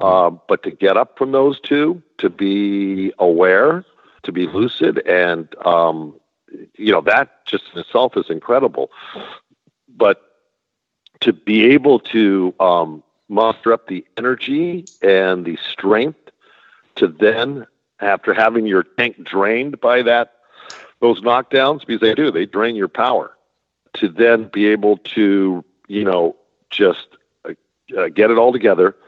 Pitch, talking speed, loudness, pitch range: 105 Hz, 140 wpm, -16 LUFS, 95-120 Hz